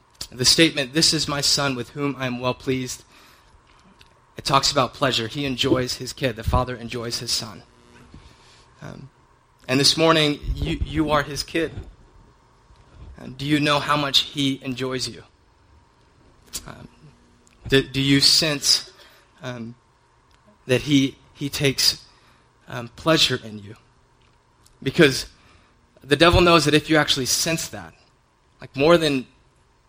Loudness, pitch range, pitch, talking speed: -20 LUFS, 120-145 Hz, 135 Hz, 140 wpm